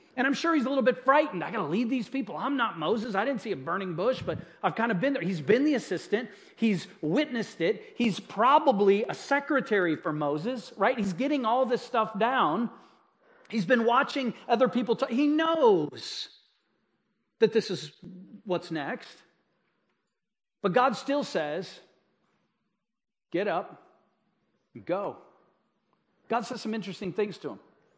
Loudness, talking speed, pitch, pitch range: -28 LUFS, 165 wpm, 230 Hz, 200-270 Hz